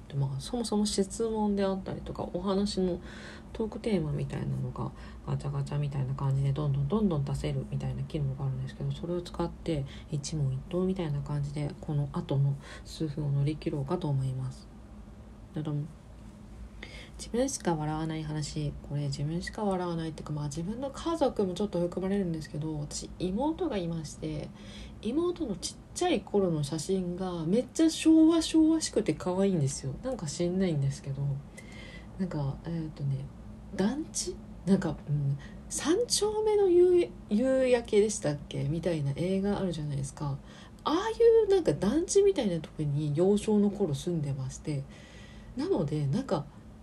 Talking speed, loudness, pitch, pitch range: 350 characters per minute, -30 LUFS, 165 Hz, 145-200 Hz